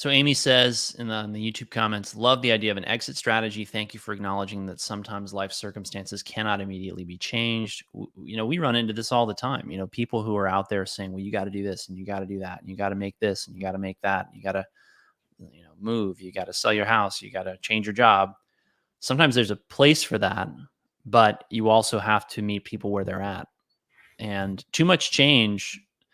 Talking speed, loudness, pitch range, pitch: 250 wpm, -25 LUFS, 95-115 Hz, 105 Hz